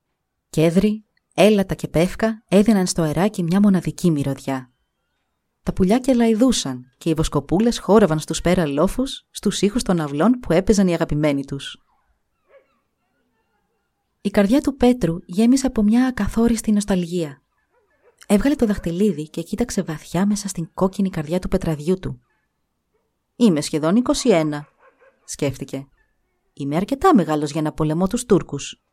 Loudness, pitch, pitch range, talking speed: -20 LUFS, 185 Hz, 155-225 Hz, 135 wpm